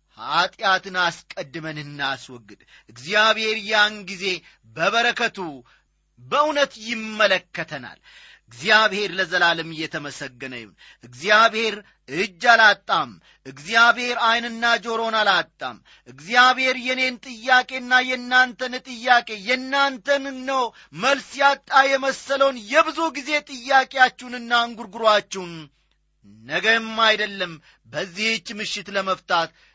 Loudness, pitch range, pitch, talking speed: -20 LUFS, 180-255 Hz, 225 Hz, 75 wpm